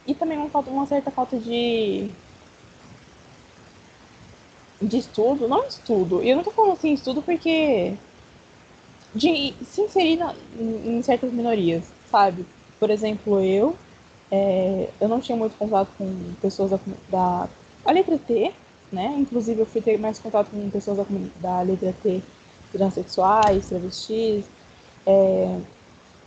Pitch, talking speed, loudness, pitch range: 220 Hz, 135 wpm, -23 LUFS, 195-265 Hz